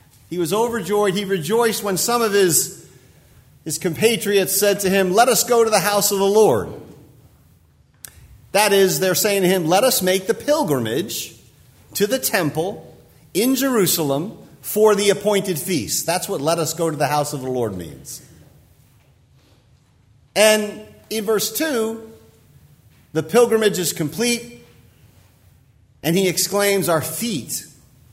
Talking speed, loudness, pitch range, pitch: 145 wpm, -18 LUFS, 165-220 Hz, 195 Hz